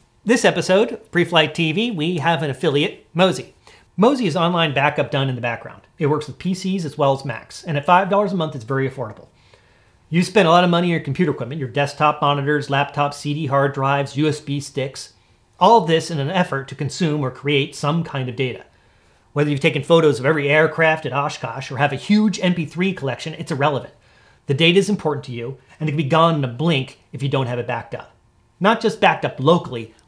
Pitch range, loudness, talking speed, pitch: 135-170 Hz, -19 LUFS, 215 wpm, 150 Hz